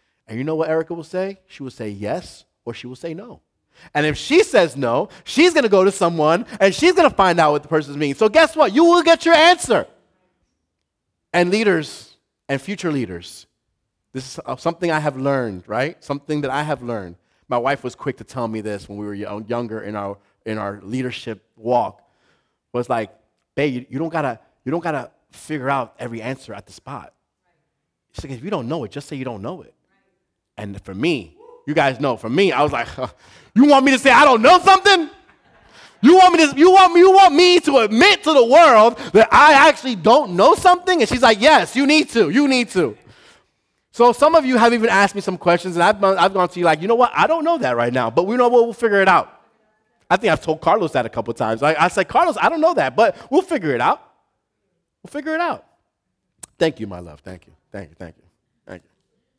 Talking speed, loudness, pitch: 230 wpm, -15 LUFS, 165 Hz